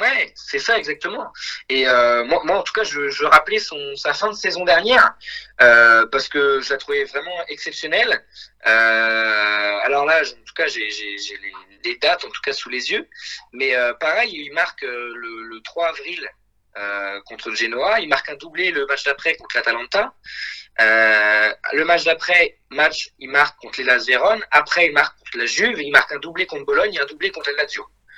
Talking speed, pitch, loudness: 200 wpm, 145 Hz, -17 LUFS